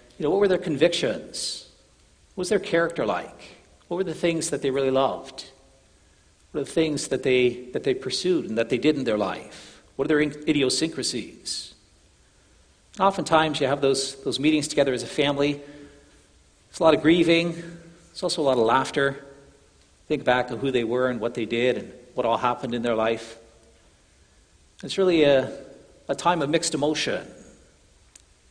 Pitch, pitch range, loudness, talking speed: 135 Hz, 115-160 Hz, -24 LUFS, 180 wpm